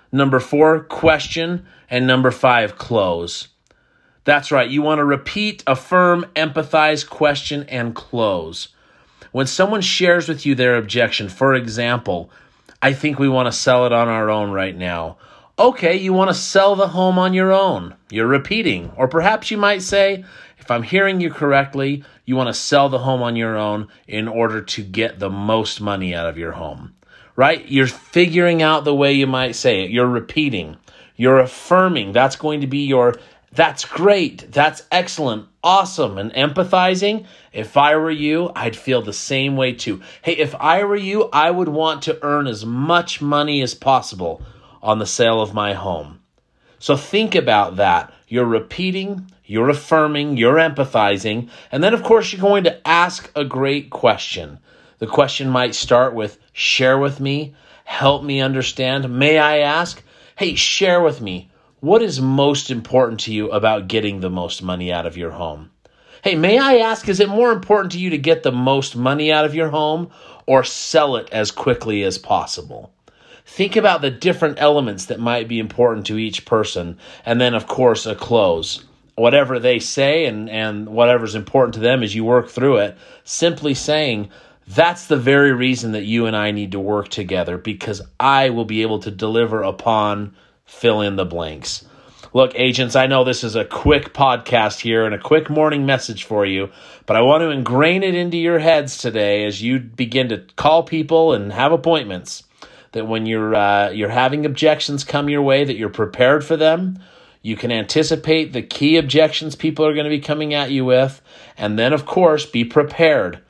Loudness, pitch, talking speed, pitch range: -17 LUFS, 135 Hz, 185 wpm, 115-155 Hz